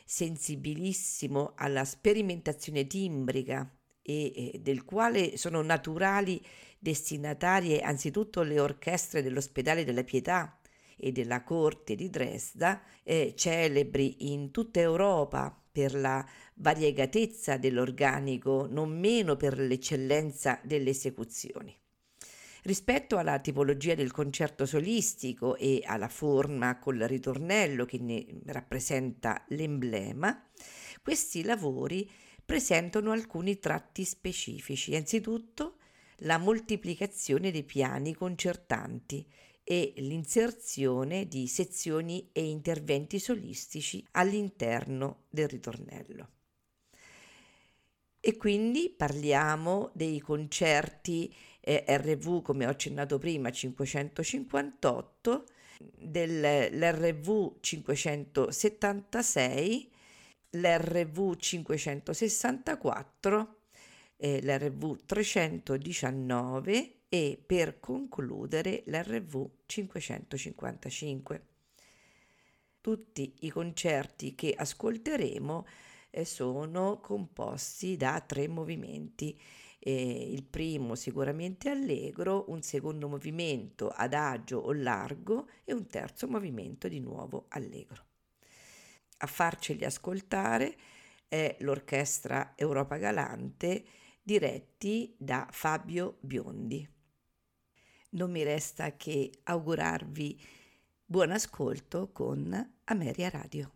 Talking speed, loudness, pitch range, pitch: 85 wpm, -32 LUFS, 140-185 Hz, 150 Hz